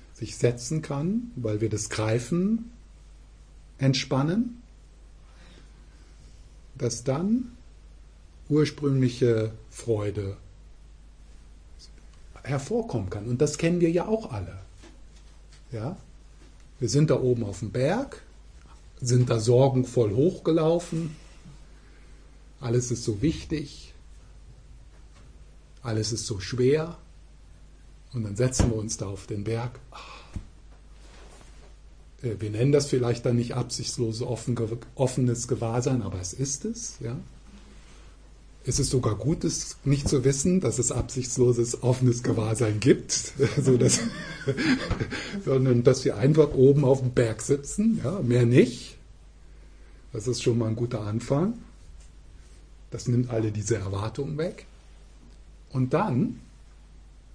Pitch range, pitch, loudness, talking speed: 85-135 Hz, 120 Hz, -26 LUFS, 110 wpm